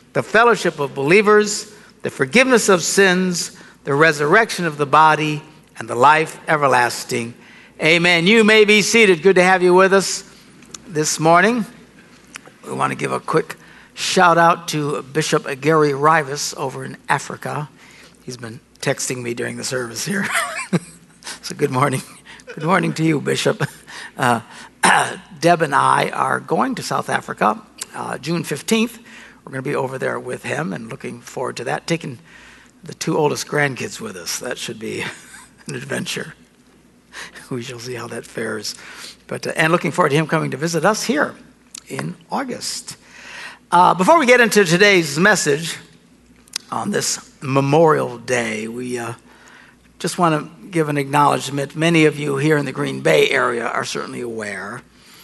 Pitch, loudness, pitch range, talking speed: 160 Hz, -17 LUFS, 145-195 Hz, 165 wpm